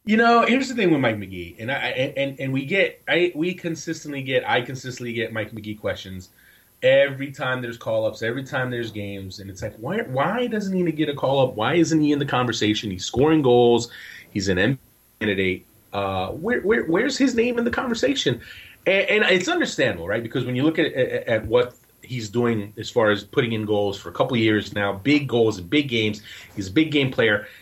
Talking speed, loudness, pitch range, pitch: 220 wpm, -22 LUFS, 105-160 Hz, 130 Hz